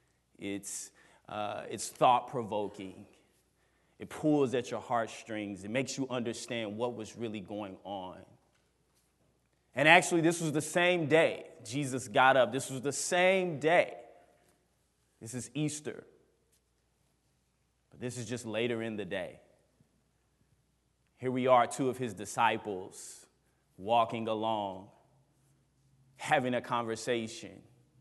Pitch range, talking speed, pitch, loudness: 105-135 Hz, 120 wpm, 120 Hz, -31 LUFS